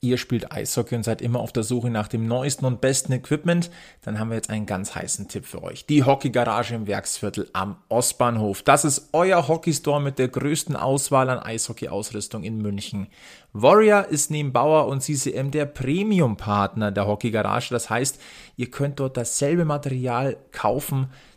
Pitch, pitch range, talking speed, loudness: 130 Hz, 115-145 Hz, 185 wpm, -23 LUFS